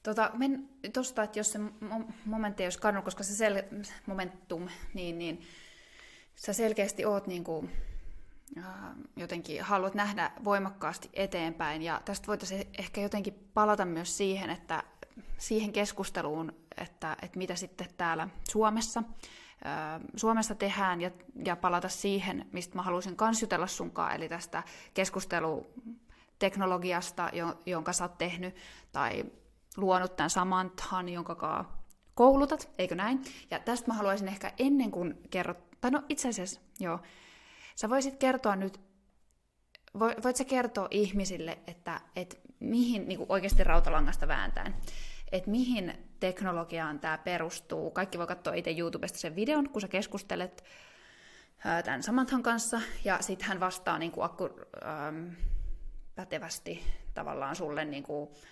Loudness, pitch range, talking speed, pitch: -33 LUFS, 175-215 Hz, 130 wpm, 190 Hz